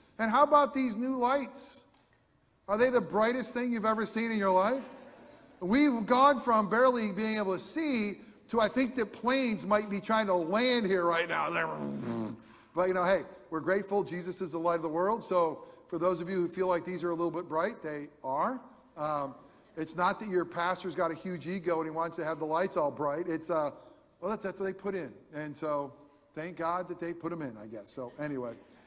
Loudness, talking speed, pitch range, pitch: -31 LUFS, 225 wpm, 165-230 Hz, 185 Hz